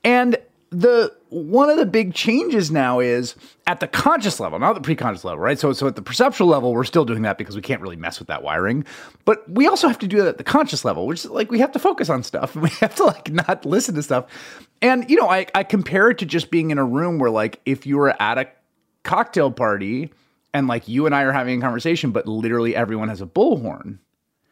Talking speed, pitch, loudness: 245 wpm, 155 Hz, -19 LUFS